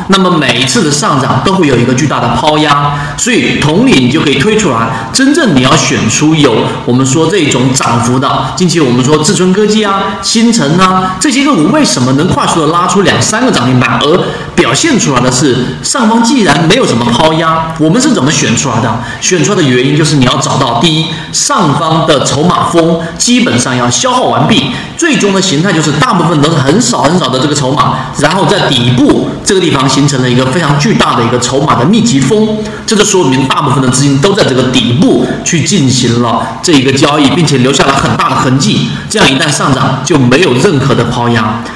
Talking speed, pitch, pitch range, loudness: 325 characters per minute, 150 Hz, 130-185 Hz, -8 LUFS